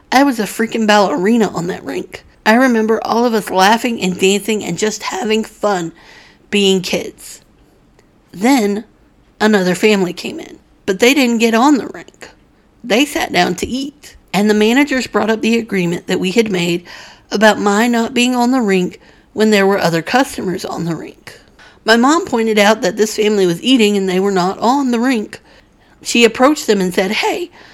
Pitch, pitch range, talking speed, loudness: 215 Hz, 195-240 Hz, 190 wpm, -14 LUFS